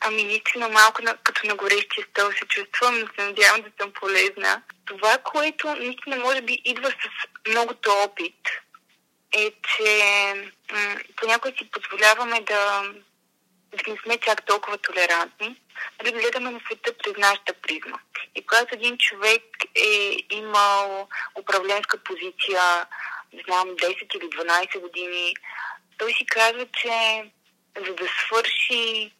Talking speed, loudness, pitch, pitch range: 135 wpm, -22 LUFS, 215 Hz, 200-240 Hz